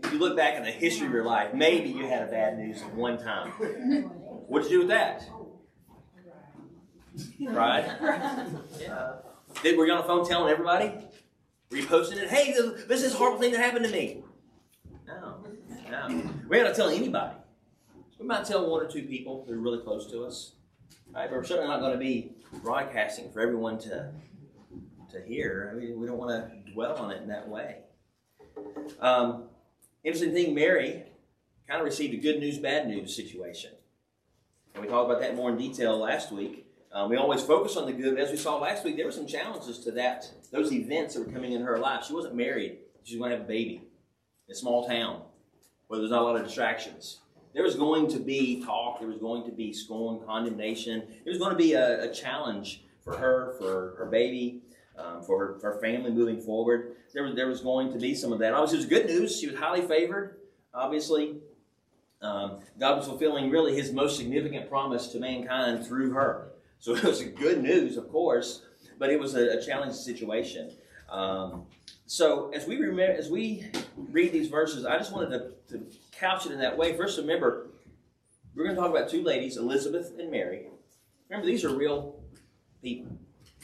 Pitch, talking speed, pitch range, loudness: 130 Hz, 200 wpm, 120-170 Hz, -29 LUFS